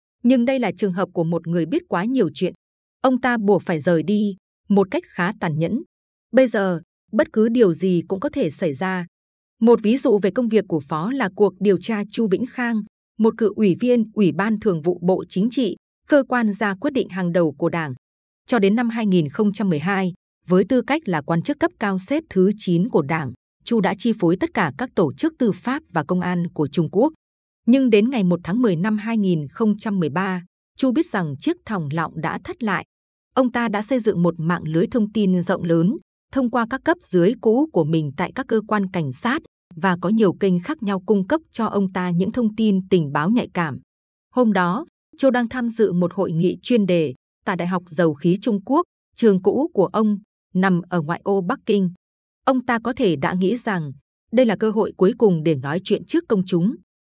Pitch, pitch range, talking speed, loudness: 200 Hz, 180-235 Hz, 220 wpm, -21 LUFS